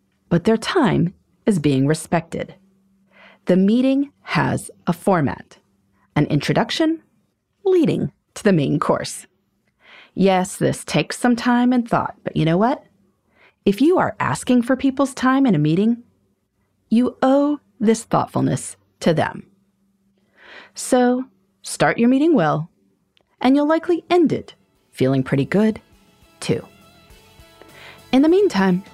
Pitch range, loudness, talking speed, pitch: 175-255 Hz, -19 LUFS, 130 wpm, 205 Hz